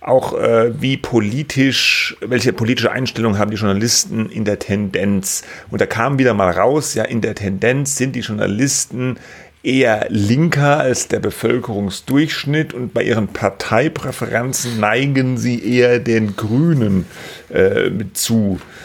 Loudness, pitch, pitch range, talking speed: -16 LUFS, 120 Hz, 110-130 Hz, 135 wpm